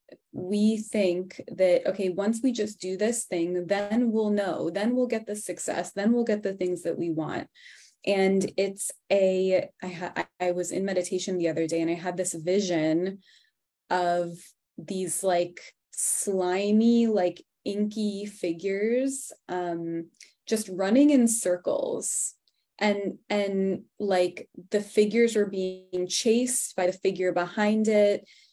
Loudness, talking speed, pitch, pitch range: -27 LUFS, 145 wpm, 195 Hz, 180-215 Hz